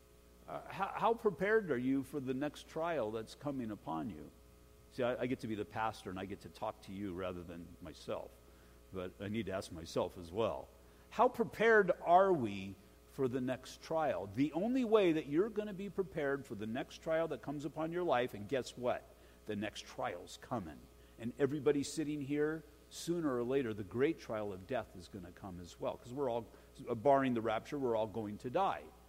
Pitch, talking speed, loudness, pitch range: 120 Hz, 210 wpm, -37 LUFS, 95-150 Hz